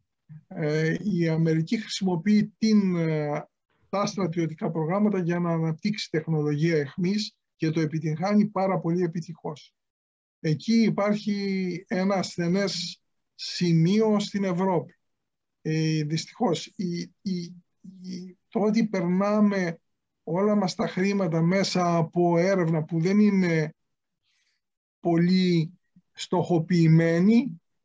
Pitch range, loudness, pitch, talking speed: 165-200 Hz, -25 LUFS, 180 Hz, 95 wpm